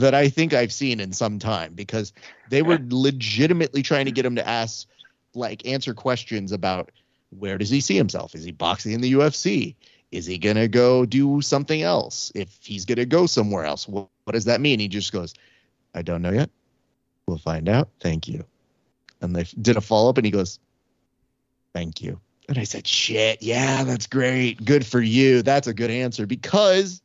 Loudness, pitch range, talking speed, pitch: -22 LUFS, 100-135 Hz, 200 wpm, 120 Hz